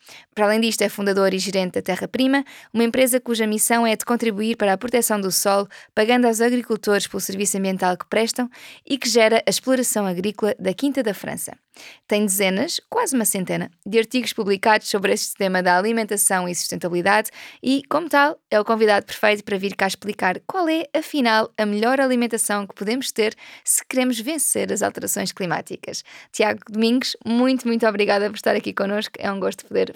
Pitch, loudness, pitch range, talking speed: 220 Hz, -20 LUFS, 200-245 Hz, 190 wpm